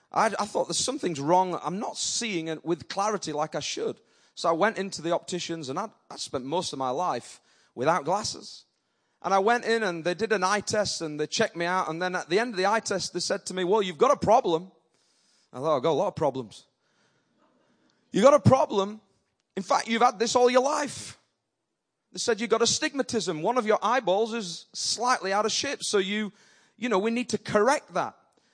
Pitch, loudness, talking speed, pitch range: 205 Hz, -26 LUFS, 225 wpm, 180-230 Hz